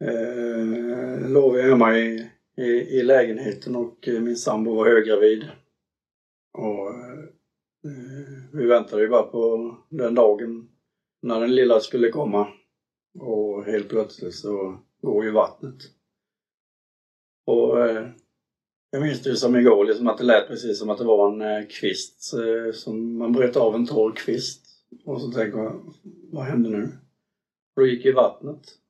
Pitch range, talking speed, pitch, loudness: 110-130 Hz, 145 wpm, 120 Hz, -22 LUFS